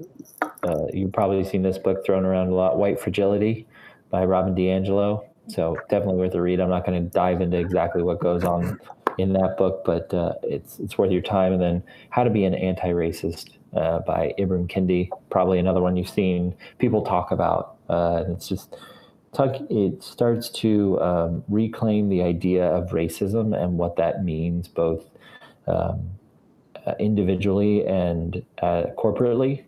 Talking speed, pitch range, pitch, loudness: 170 wpm, 90-100 Hz, 95 Hz, -23 LUFS